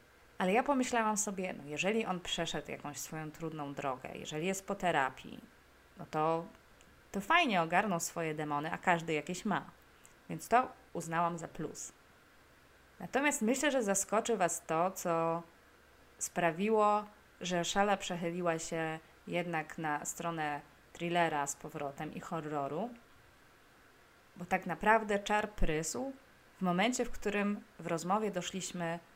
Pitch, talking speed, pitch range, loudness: 175 Hz, 130 wpm, 160-205 Hz, -35 LUFS